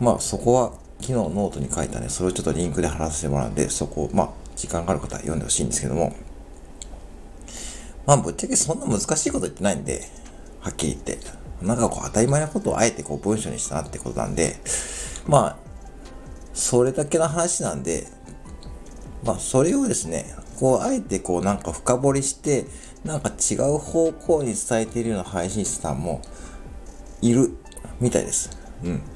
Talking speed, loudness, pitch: 380 characters per minute, -23 LUFS, 90 Hz